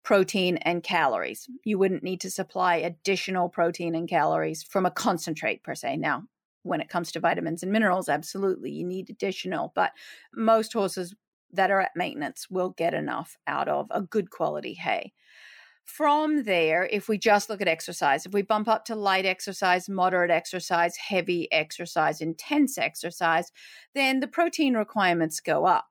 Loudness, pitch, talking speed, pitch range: -26 LUFS, 185 Hz, 165 wpm, 170-215 Hz